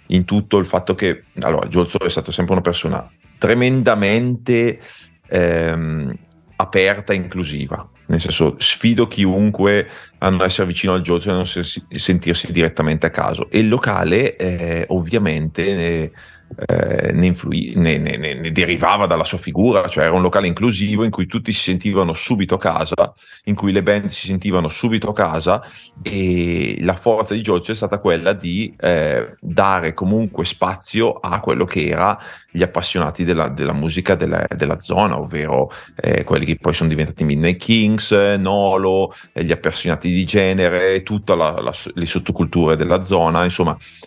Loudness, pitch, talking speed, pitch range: -17 LUFS, 90 Hz, 160 wpm, 85-100 Hz